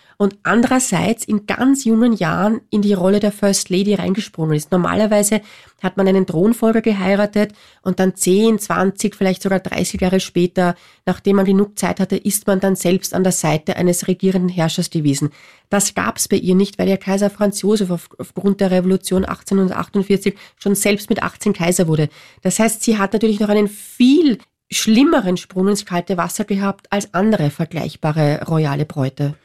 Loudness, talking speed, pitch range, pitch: -17 LUFS, 175 wpm, 180-205 Hz, 195 Hz